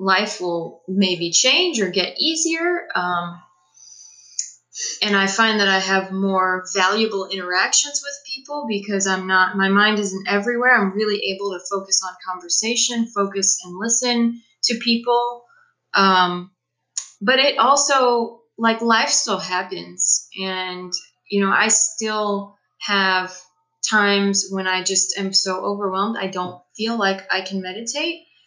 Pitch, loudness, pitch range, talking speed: 195 Hz, -19 LUFS, 185-230 Hz, 140 wpm